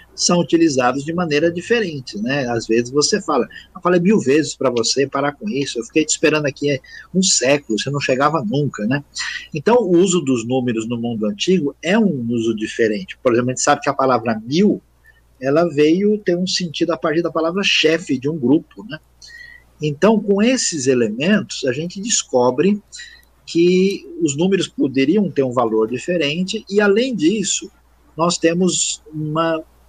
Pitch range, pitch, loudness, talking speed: 135-190 Hz, 160 Hz, -18 LUFS, 175 wpm